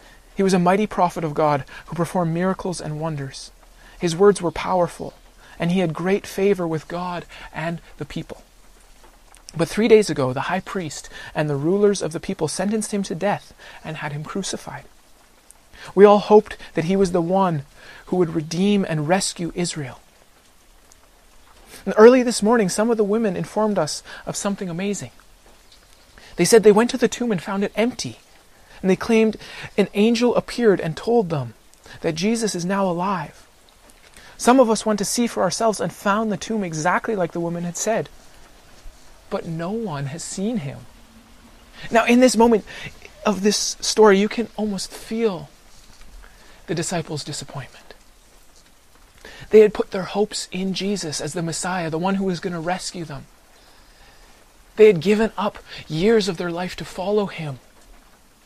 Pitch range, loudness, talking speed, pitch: 165-210 Hz, -20 LUFS, 170 wpm, 190 Hz